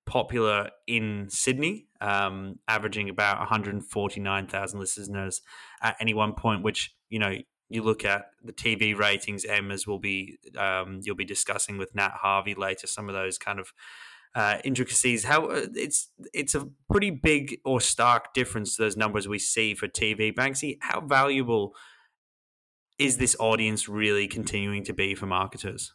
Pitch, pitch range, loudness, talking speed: 105 Hz, 100-115 Hz, -27 LUFS, 165 wpm